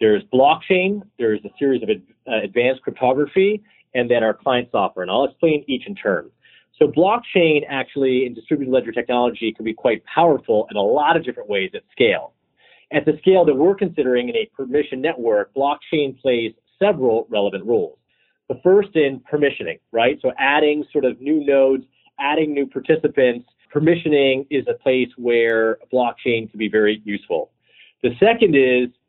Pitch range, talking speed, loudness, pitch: 125-180 Hz, 165 wpm, -19 LUFS, 140 Hz